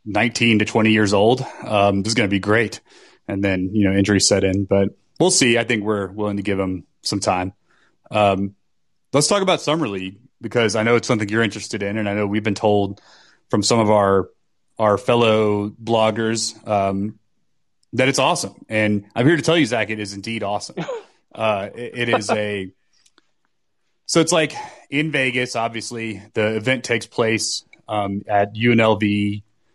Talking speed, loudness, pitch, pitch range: 185 wpm, -19 LUFS, 110 Hz, 100-120 Hz